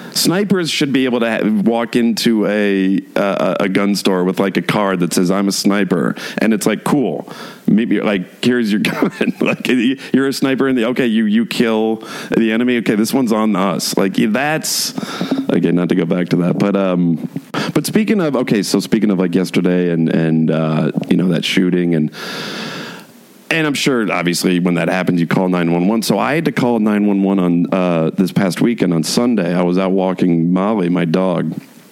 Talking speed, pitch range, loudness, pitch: 200 wpm, 90-110 Hz, -15 LUFS, 95 Hz